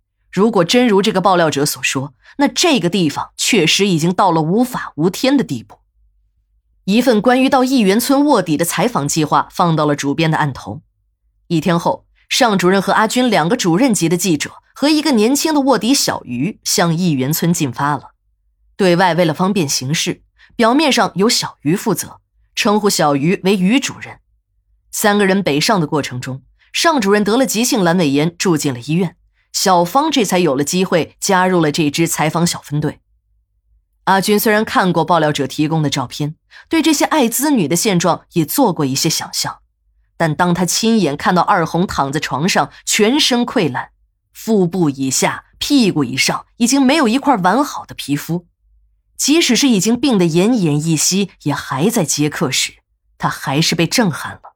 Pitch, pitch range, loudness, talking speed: 180 Hz, 155-225 Hz, -15 LUFS, 265 characters per minute